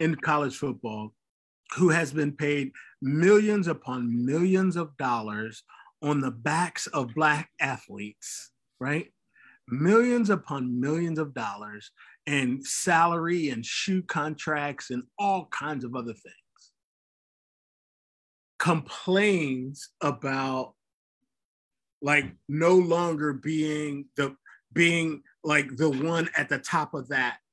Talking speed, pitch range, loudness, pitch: 110 wpm, 135-165 Hz, -27 LUFS, 150 Hz